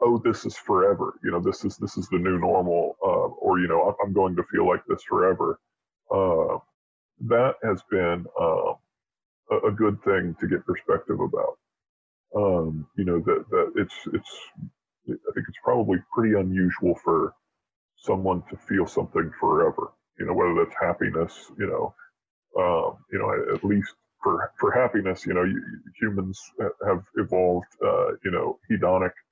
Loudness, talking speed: -25 LUFS, 165 wpm